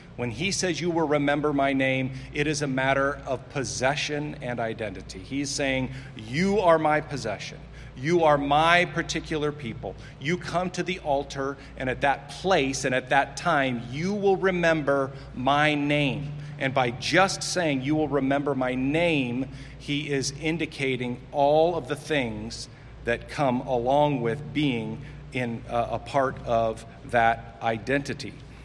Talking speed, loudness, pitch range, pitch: 150 wpm, -26 LUFS, 130-150 Hz, 140 Hz